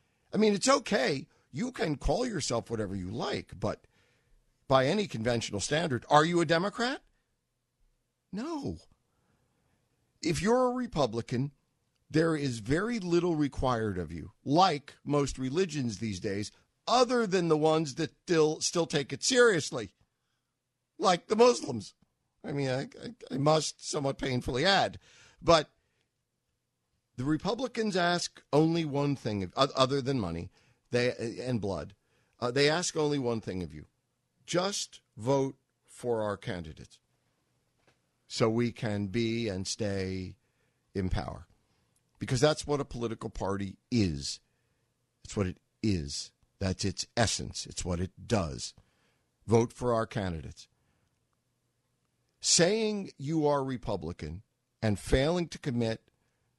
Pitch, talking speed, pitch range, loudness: 130 Hz, 130 wpm, 110-155 Hz, -30 LUFS